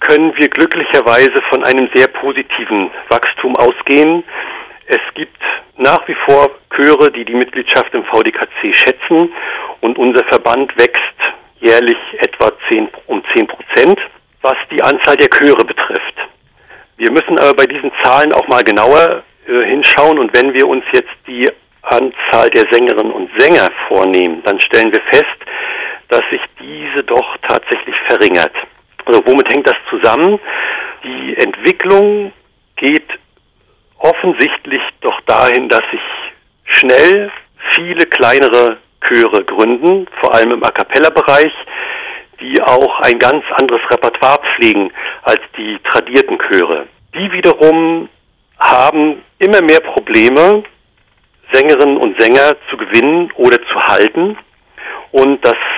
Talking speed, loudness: 130 wpm, -10 LUFS